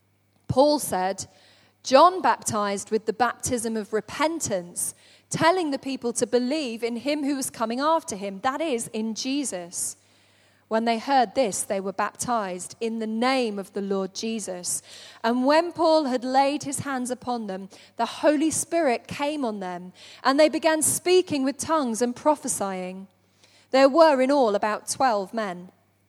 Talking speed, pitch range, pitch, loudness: 160 wpm, 200-280 Hz, 235 Hz, -24 LUFS